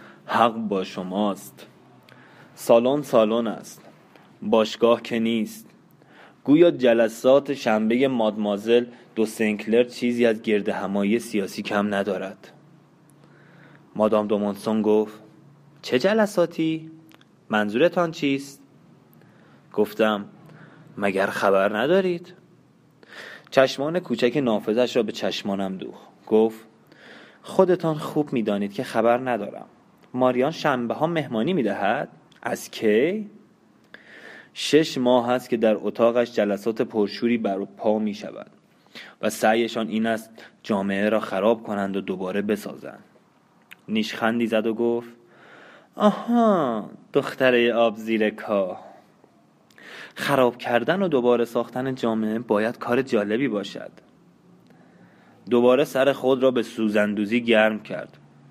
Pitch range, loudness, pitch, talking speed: 105-135 Hz, -23 LUFS, 115 Hz, 110 wpm